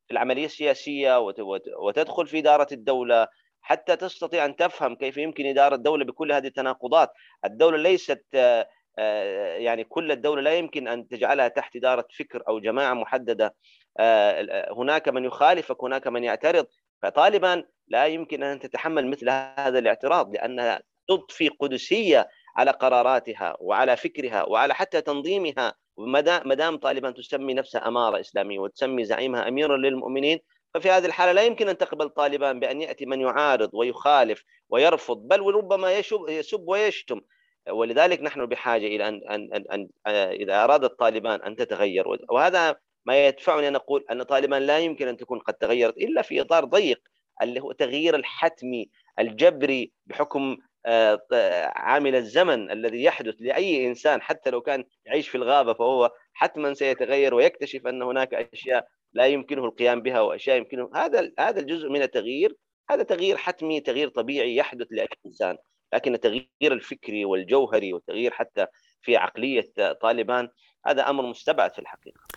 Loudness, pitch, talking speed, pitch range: -24 LUFS, 140 Hz, 145 wpm, 130-185 Hz